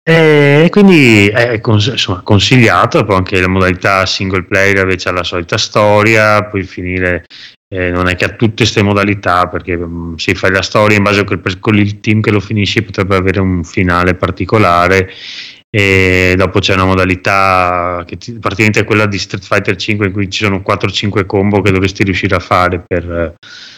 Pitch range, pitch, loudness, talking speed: 90-105 Hz, 100 Hz, -11 LUFS, 180 wpm